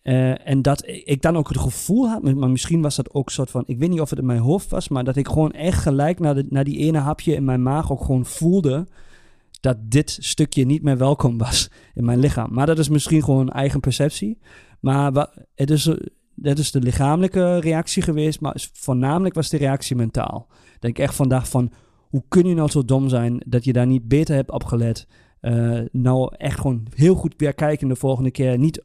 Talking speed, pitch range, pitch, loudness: 225 wpm, 130-155 Hz, 140 Hz, -20 LUFS